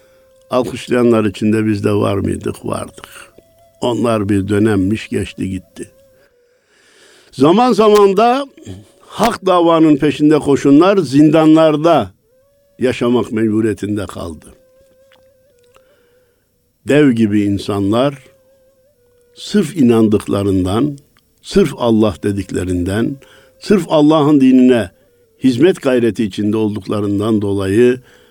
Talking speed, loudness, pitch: 85 wpm, -13 LUFS, 135 Hz